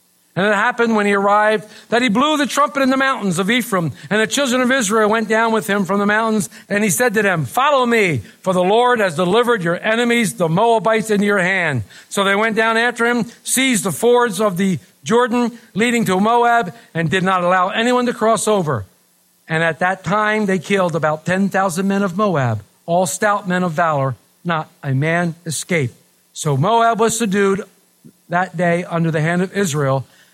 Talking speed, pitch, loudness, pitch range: 200 wpm, 200 Hz, -17 LUFS, 175-230 Hz